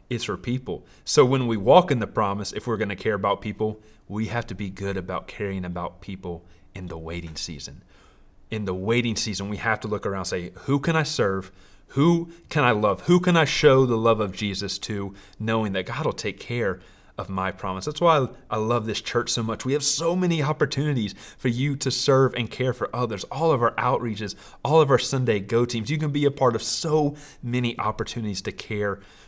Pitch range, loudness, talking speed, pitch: 100-130 Hz, -24 LUFS, 225 wpm, 110 Hz